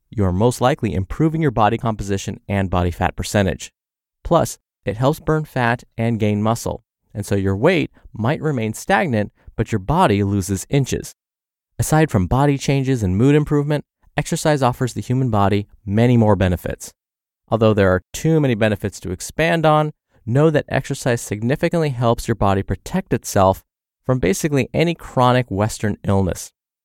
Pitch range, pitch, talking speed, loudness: 100-140 Hz, 115 Hz, 160 wpm, -19 LUFS